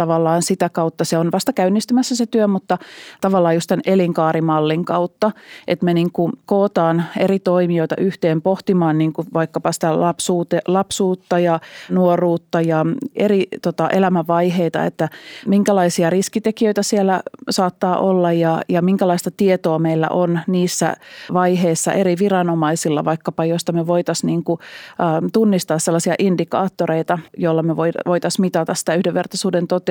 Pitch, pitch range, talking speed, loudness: 175 Hz, 165-190 Hz, 140 wpm, -18 LUFS